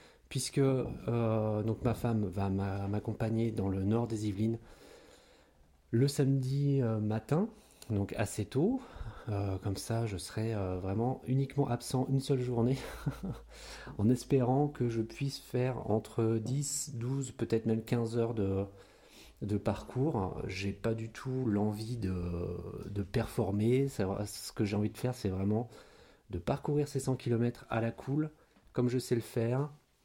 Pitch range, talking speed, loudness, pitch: 105-130 Hz, 150 wpm, -34 LUFS, 115 Hz